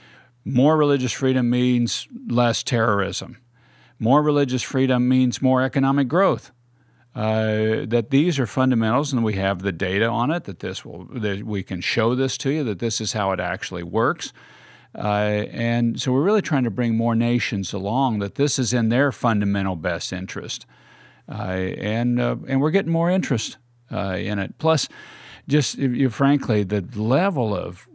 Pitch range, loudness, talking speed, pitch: 105-135 Hz, -22 LUFS, 170 wpm, 120 Hz